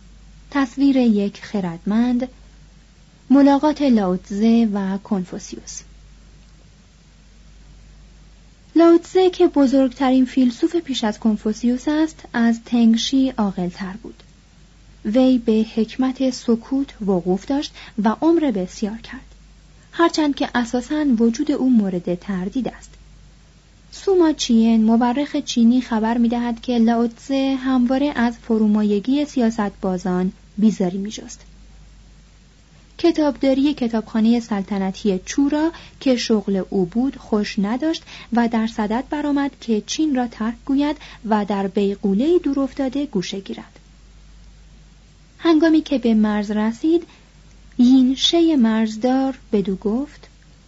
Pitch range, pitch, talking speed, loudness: 215-275 Hz, 240 Hz, 105 wpm, -19 LUFS